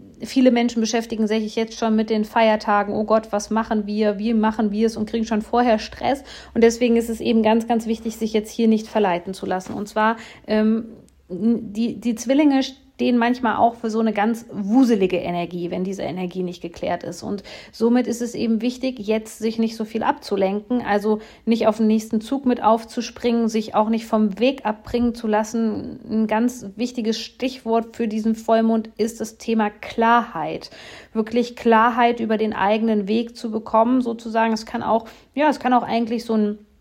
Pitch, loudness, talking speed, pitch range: 225 Hz, -21 LUFS, 190 wpm, 215-235 Hz